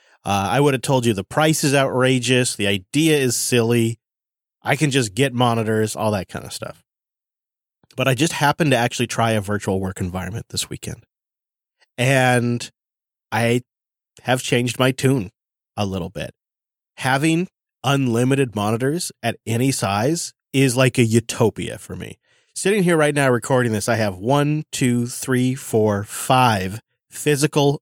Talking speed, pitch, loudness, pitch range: 155 wpm, 125 Hz, -20 LUFS, 110-140 Hz